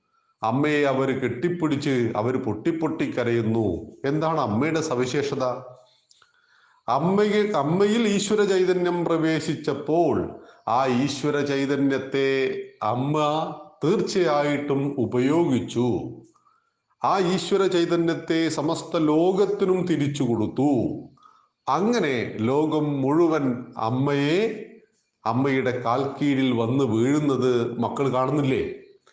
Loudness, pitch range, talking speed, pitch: -23 LUFS, 130-175 Hz, 75 wpm, 145 Hz